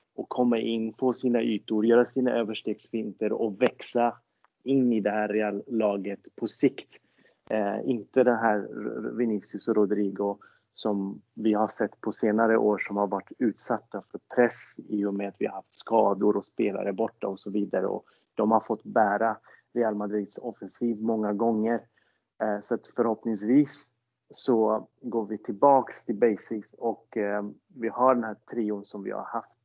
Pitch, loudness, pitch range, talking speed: 110 Hz, -27 LUFS, 105-120 Hz, 165 wpm